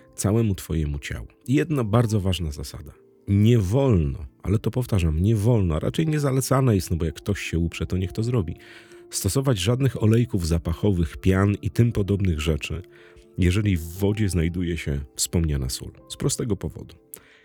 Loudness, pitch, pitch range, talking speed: -23 LUFS, 100 Hz, 85-115 Hz, 160 wpm